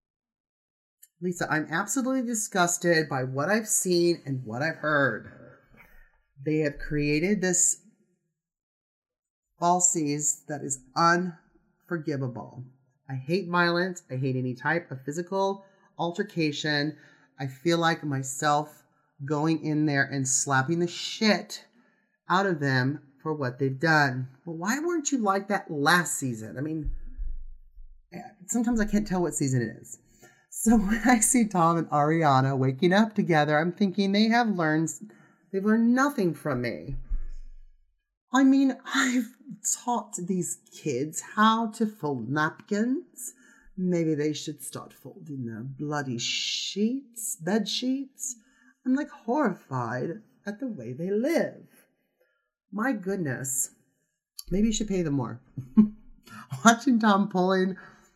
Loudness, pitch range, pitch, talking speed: -26 LUFS, 145-210 Hz, 170 Hz, 130 wpm